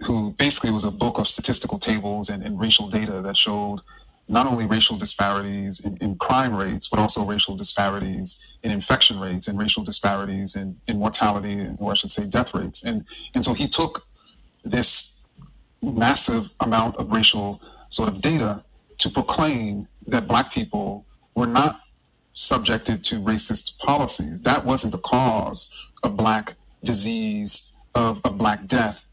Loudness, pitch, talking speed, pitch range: -22 LUFS, 105 Hz, 160 wpm, 100-115 Hz